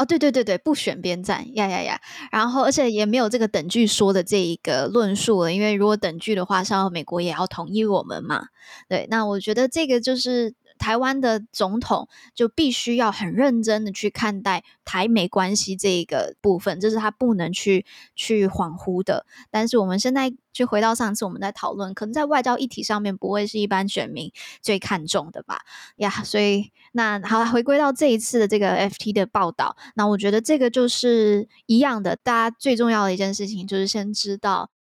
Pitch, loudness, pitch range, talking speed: 210 Hz, -22 LUFS, 195-240 Hz, 330 characters per minute